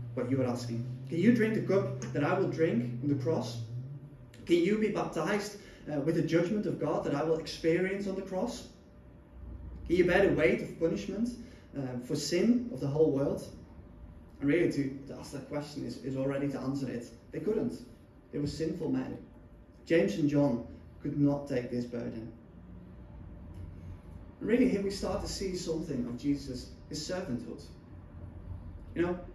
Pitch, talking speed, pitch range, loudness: 145 Hz, 180 wpm, 120-170 Hz, -32 LUFS